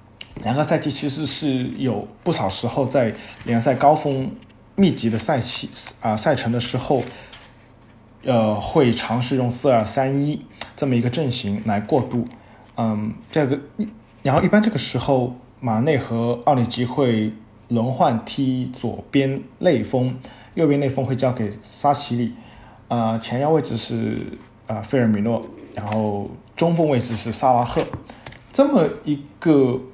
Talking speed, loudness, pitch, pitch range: 220 characters per minute, -21 LUFS, 125 Hz, 115-140 Hz